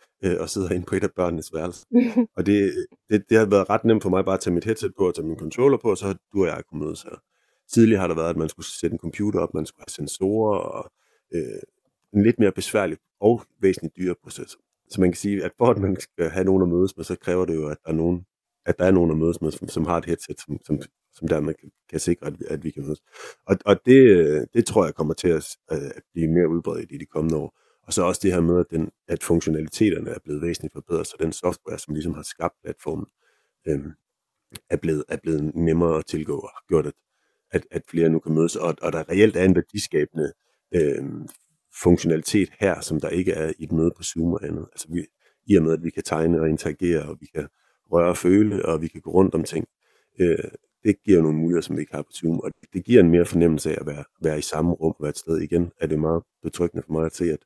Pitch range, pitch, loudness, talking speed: 80-95 Hz, 85 Hz, -23 LUFS, 260 wpm